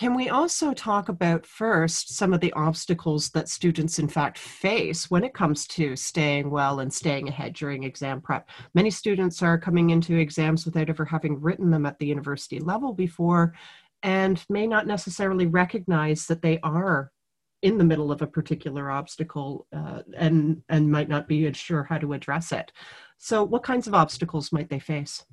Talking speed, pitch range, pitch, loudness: 180 wpm, 150-180 Hz, 160 Hz, -25 LUFS